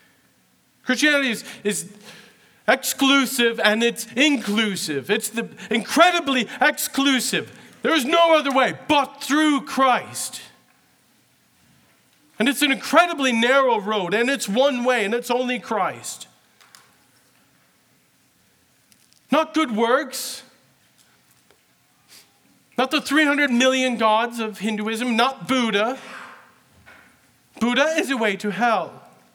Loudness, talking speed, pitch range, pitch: -20 LUFS, 105 wpm, 225-275 Hz, 255 Hz